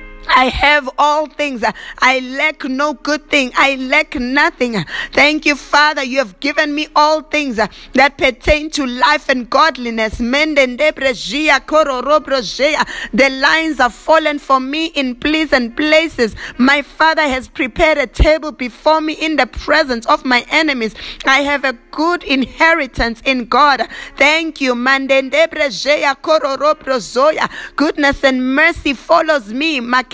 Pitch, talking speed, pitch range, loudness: 285 Hz, 125 wpm, 260-305 Hz, -14 LUFS